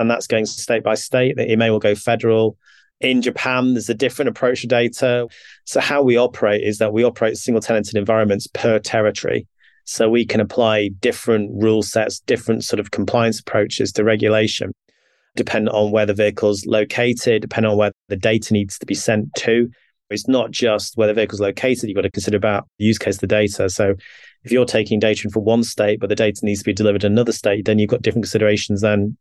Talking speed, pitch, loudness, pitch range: 215 wpm, 110 Hz, -18 LUFS, 105-115 Hz